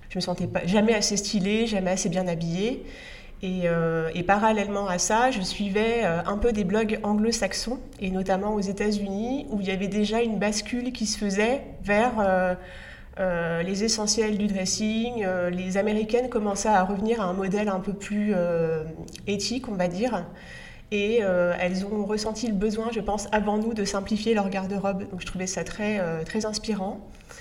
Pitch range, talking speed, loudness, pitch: 185-220 Hz, 185 wpm, -26 LUFS, 205 Hz